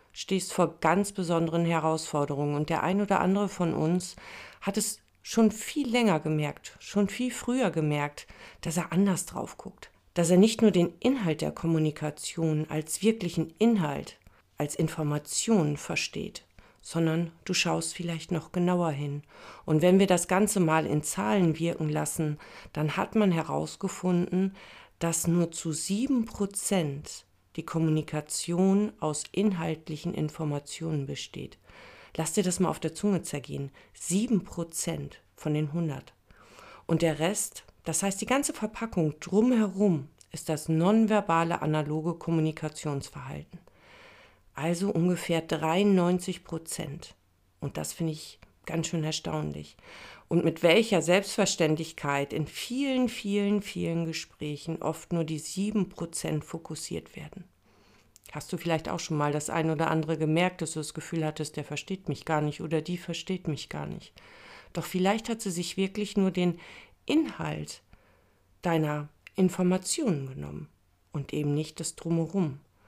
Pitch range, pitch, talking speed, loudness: 155-190 Hz, 165 Hz, 140 wpm, -29 LUFS